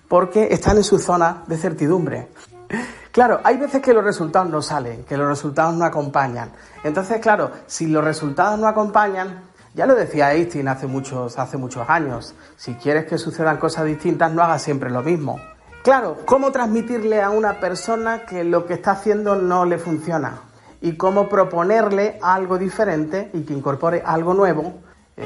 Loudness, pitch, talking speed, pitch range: -19 LUFS, 170 Hz, 170 wpm, 150-205 Hz